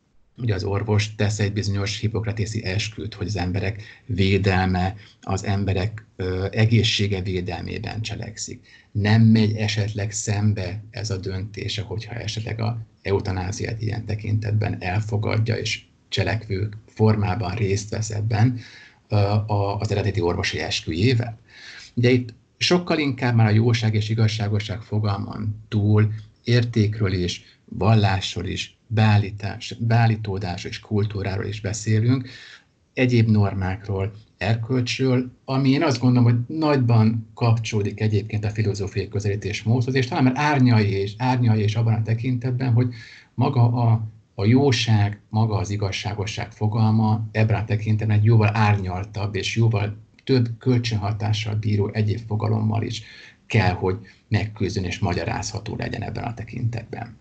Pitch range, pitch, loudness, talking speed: 100-115 Hz, 110 Hz, -23 LUFS, 125 wpm